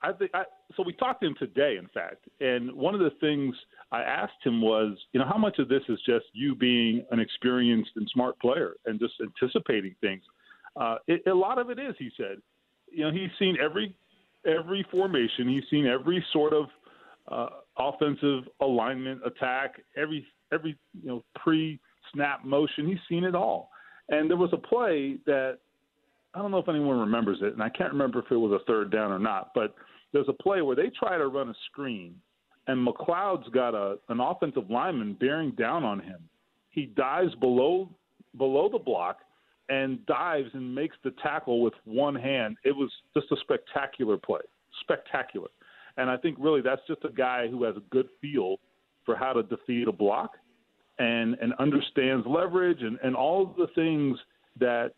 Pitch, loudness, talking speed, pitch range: 140 Hz, -28 LUFS, 190 wpm, 125-170 Hz